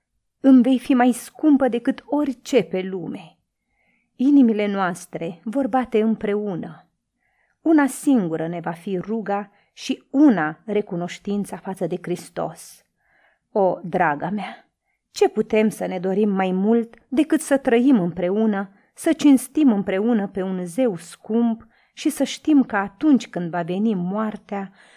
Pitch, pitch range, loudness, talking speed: 215 Hz, 190-260 Hz, -21 LUFS, 135 wpm